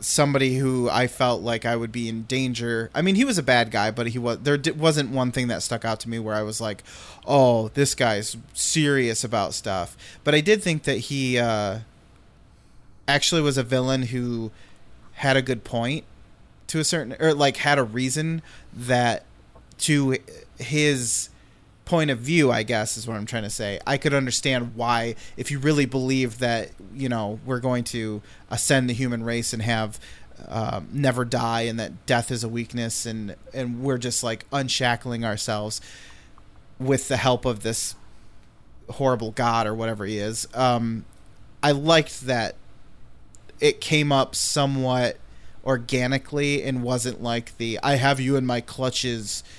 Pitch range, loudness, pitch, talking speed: 115-135 Hz, -24 LUFS, 125 Hz, 175 wpm